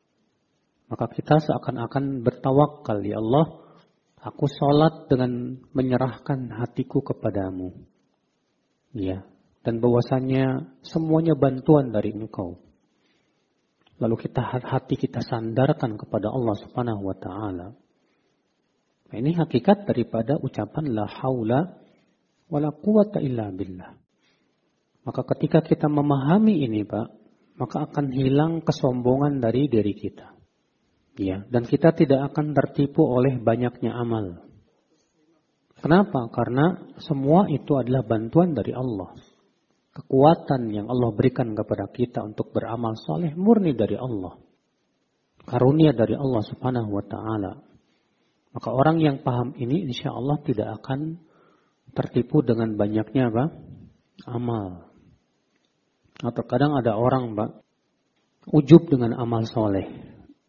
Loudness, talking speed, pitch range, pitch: -23 LUFS, 110 wpm, 115-145 Hz, 130 Hz